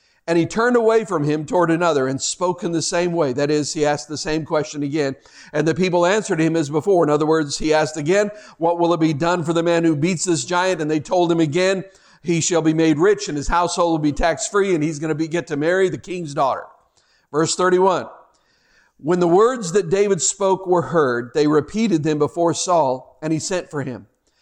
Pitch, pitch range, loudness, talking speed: 165 Hz, 155-180 Hz, -19 LUFS, 235 wpm